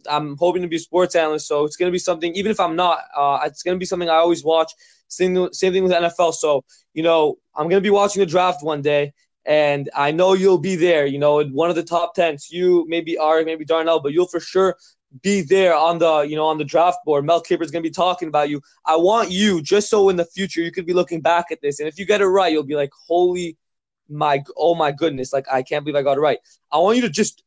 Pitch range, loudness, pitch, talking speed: 150-180 Hz, -19 LUFS, 170 Hz, 270 wpm